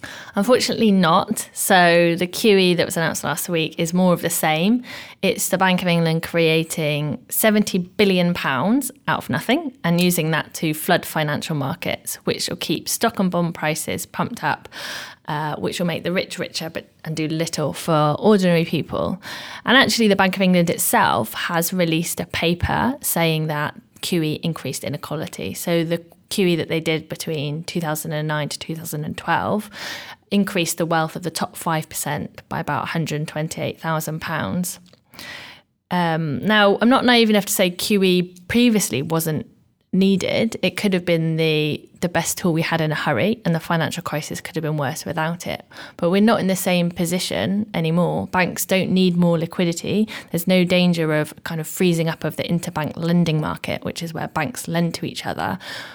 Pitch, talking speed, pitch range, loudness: 170 Hz, 175 wpm, 160-190 Hz, -20 LUFS